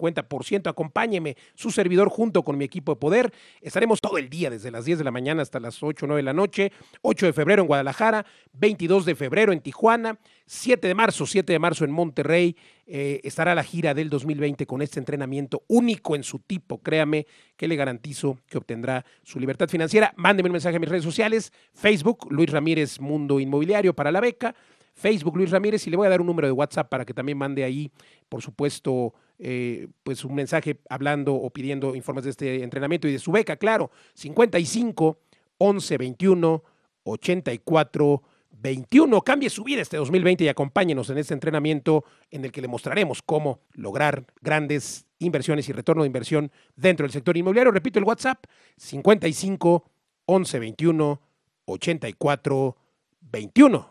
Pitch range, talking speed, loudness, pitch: 140-190 Hz, 185 wpm, -23 LUFS, 155 Hz